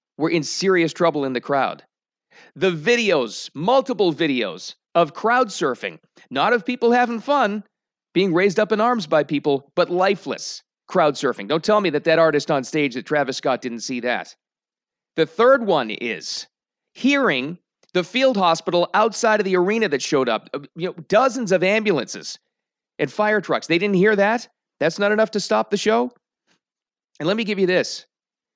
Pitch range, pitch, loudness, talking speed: 160-220 Hz, 190 Hz, -20 LUFS, 175 wpm